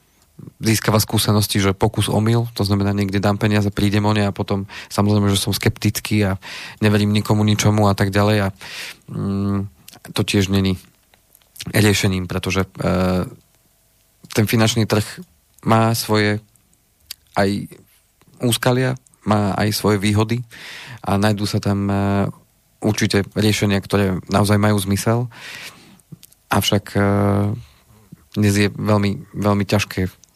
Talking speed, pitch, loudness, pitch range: 125 wpm, 105 Hz, -19 LUFS, 100-110 Hz